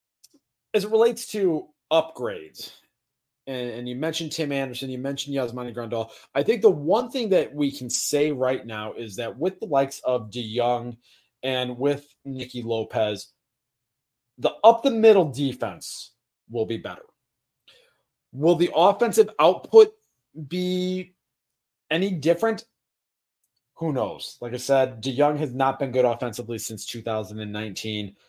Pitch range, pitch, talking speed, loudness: 120-175 Hz, 135 Hz, 145 wpm, -24 LUFS